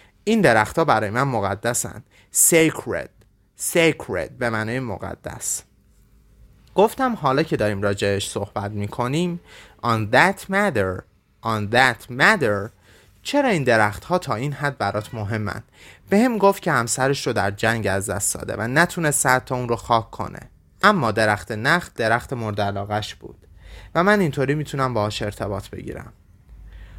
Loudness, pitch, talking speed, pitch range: -21 LUFS, 115 Hz, 145 wpm, 105-150 Hz